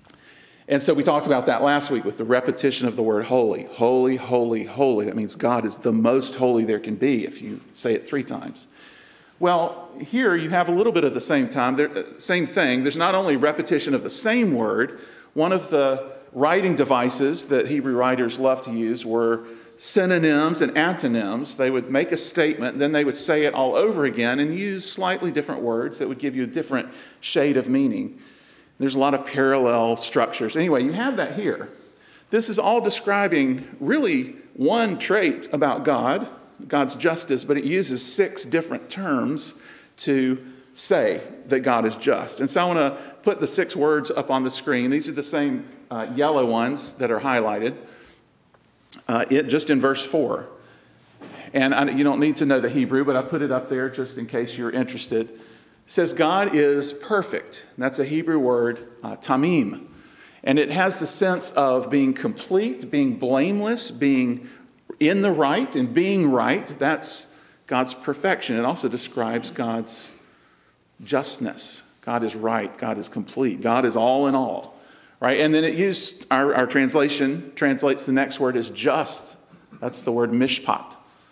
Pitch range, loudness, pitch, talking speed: 125-175 Hz, -22 LUFS, 140 Hz, 180 wpm